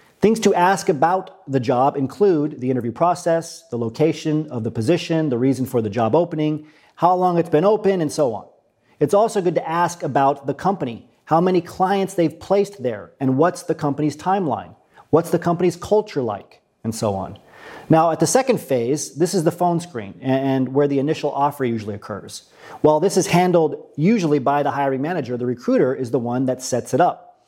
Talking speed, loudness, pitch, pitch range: 200 wpm, -20 LUFS, 155 Hz, 130-175 Hz